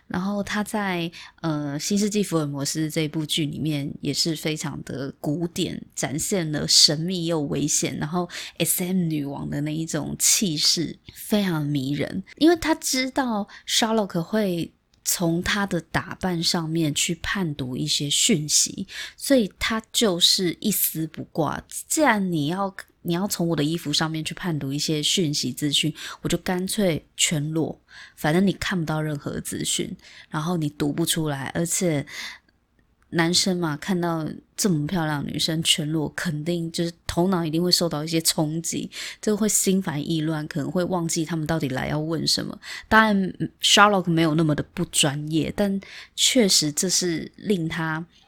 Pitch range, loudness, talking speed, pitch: 155-185 Hz, -23 LUFS, 255 characters per minute, 165 Hz